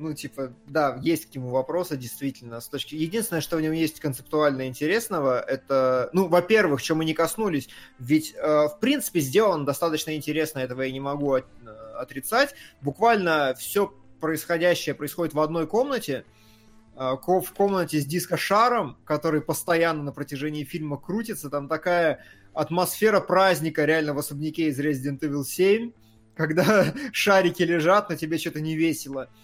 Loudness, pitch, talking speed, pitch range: -24 LUFS, 155 Hz, 150 wpm, 140-175 Hz